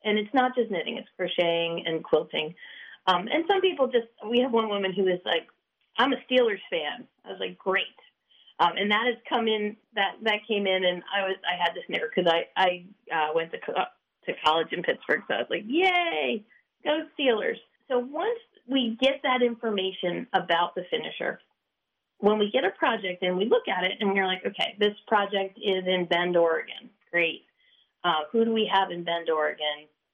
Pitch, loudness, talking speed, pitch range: 205 Hz, -26 LUFS, 200 wpm, 180-245 Hz